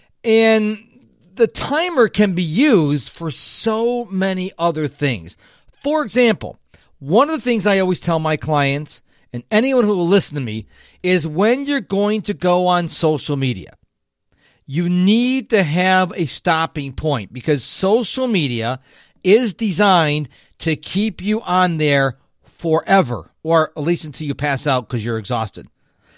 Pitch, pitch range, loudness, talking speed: 170 Hz, 145-210 Hz, -18 LUFS, 150 wpm